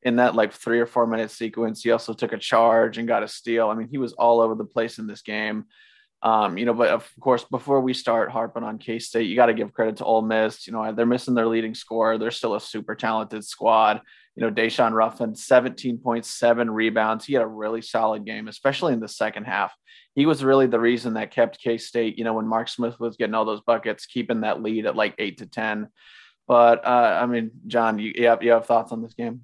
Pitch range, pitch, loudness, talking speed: 110-120 Hz, 115 Hz, -23 LUFS, 245 wpm